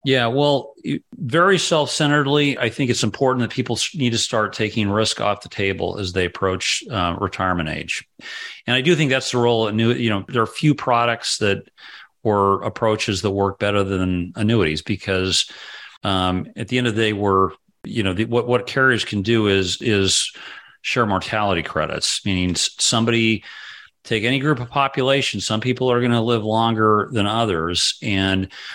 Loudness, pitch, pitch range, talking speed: -19 LUFS, 110 Hz, 100-125 Hz, 180 wpm